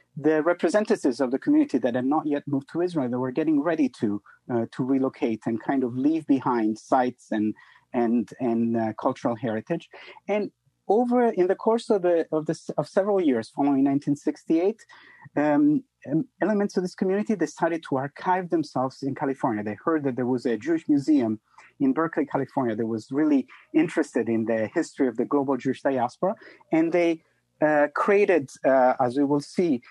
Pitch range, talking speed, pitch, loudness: 130-195 Hz, 185 wpm, 150 Hz, -25 LUFS